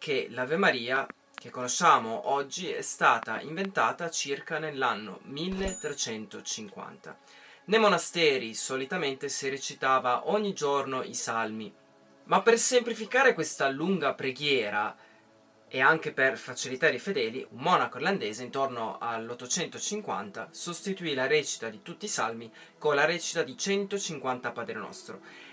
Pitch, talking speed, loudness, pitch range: 150 Hz, 120 wpm, -28 LUFS, 130-190 Hz